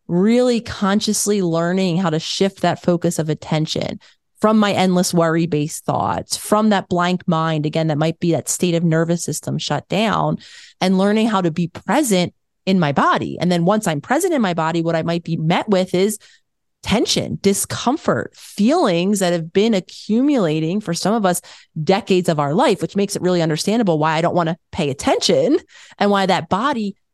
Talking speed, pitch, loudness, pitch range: 190 wpm, 180 Hz, -18 LUFS, 165-200 Hz